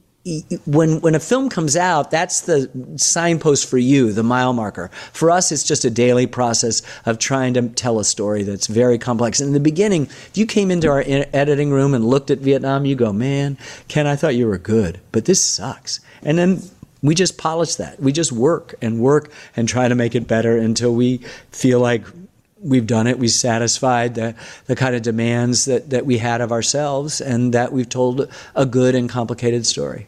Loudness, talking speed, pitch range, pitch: -17 LUFS, 210 wpm, 120-145 Hz, 130 Hz